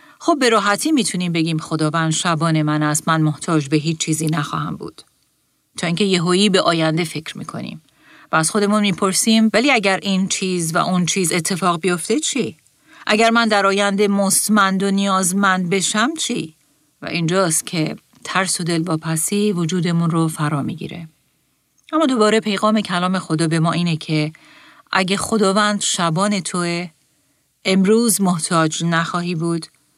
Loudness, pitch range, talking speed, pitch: -18 LUFS, 160-200 Hz, 150 wpm, 180 Hz